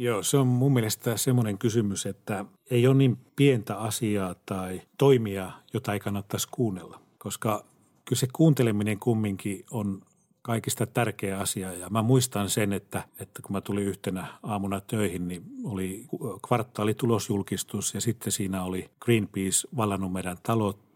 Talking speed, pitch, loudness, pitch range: 150 wpm, 105 Hz, -28 LUFS, 100-120 Hz